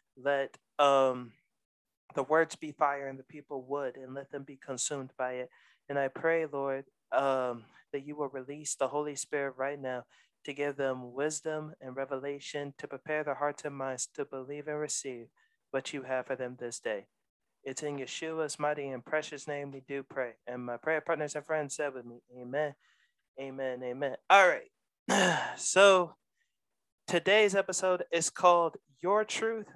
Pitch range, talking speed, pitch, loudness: 135-155 Hz, 170 wpm, 140 Hz, -32 LUFS